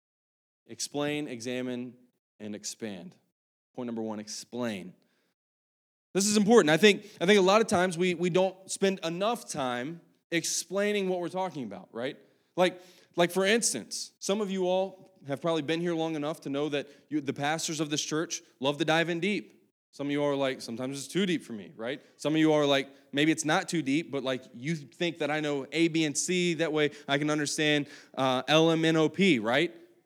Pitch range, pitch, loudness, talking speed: 140-180 Hz, 155 Hz, -28 LUFS, 210 wpm